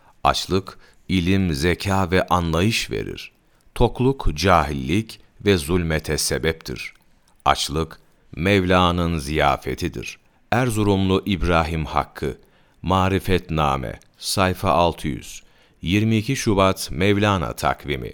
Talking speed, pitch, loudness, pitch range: 80 wpm, 90 Hz, -21 LUFS, 80-100 Hz